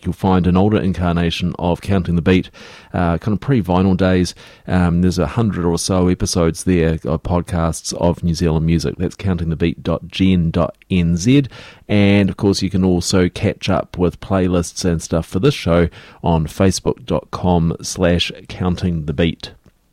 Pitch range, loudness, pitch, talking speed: 85-95 Hz, -17 LUFS, 90 Hz, 150 wpm